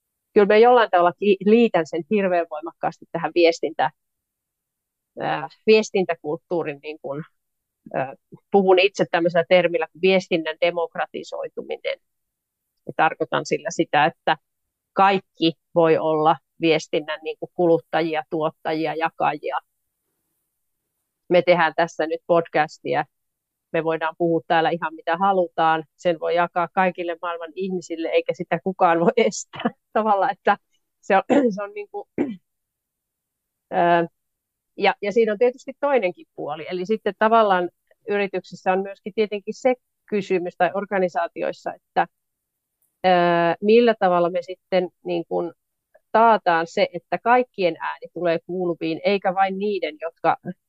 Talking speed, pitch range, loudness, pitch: 115 wpm, 165-205 Hz, -21 LUFS, 175 Hz